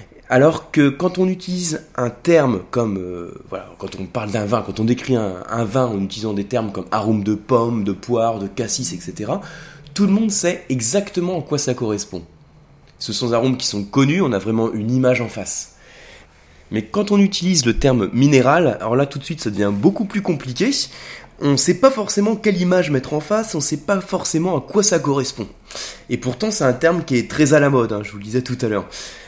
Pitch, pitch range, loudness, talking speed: 130 Hz, 110-170 Hz, -19 LUFS, 230 wpm